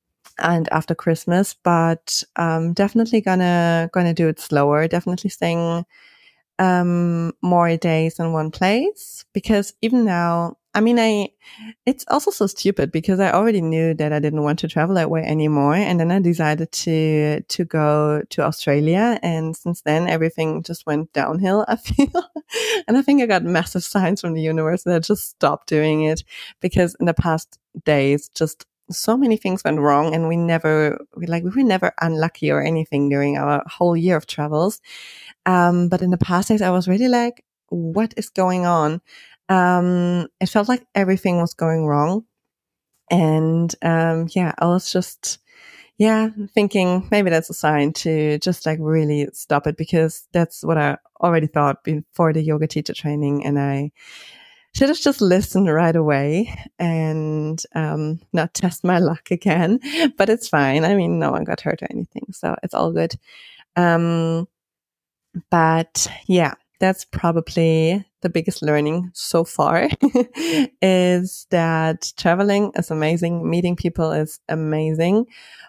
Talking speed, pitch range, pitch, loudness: 160 wpm, 155-190 Hz, 170 Hz, -19 LUFS